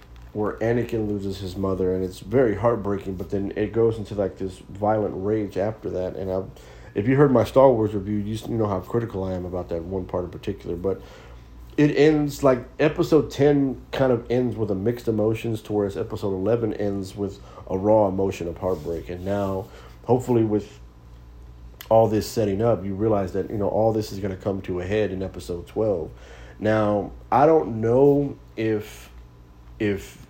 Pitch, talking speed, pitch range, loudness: 105 Hz, 190 wpm, 95-115 Hz, -23 LUFS